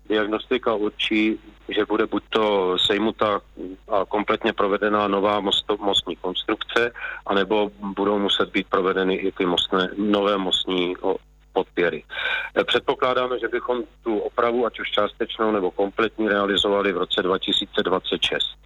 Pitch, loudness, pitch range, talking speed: 105 Hz, -22 LUFS, 100-110 Hz, 120 wpm